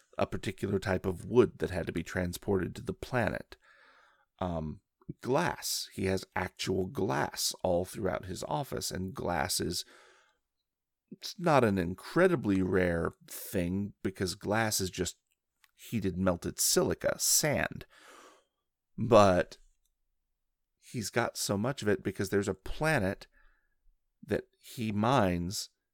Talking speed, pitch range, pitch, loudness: 125 wpm, 90-100 Hz, 95 Hz, -31 LUFS